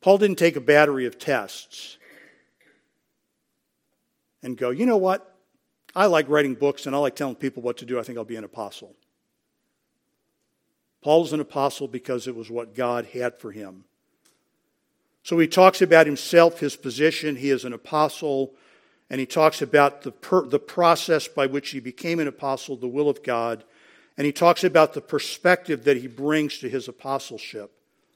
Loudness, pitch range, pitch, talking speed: -22 LUFS, 130-160 Hz, 145 Hz, 175 wpm